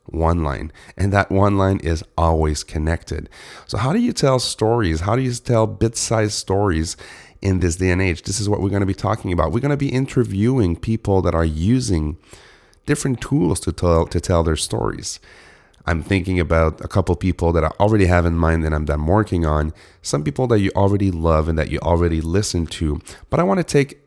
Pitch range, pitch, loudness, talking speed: 80-110 Hz, 95 Hz, -19 LUFS, 215 wpm